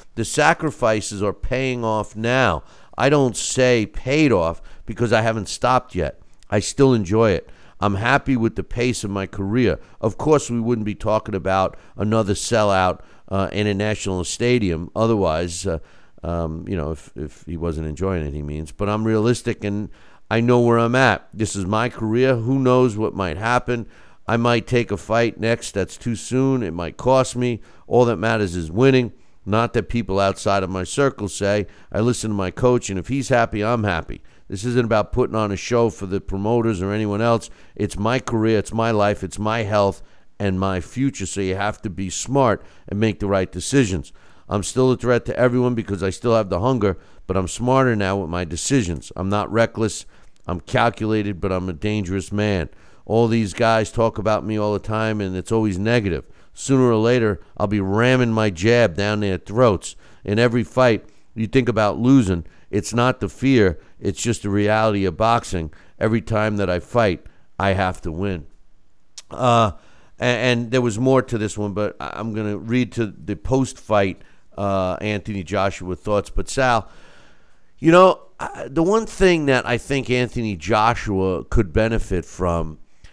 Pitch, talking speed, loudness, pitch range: 105 Hz, 190 wpm, -20 LUFS, 95-120 Hz